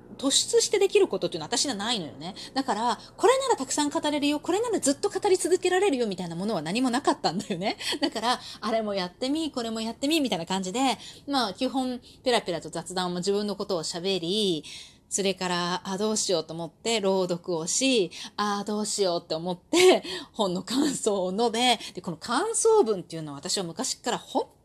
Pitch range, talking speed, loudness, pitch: 185-280 Hz, 405 characters per minute, -26 LUFS, 220 Hz